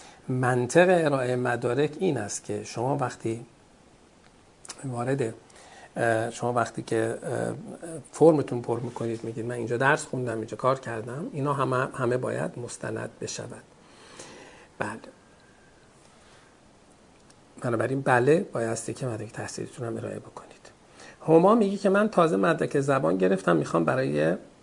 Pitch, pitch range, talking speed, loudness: 125 Hz, 115-150 Hz, 120 wpm, -26 LUFS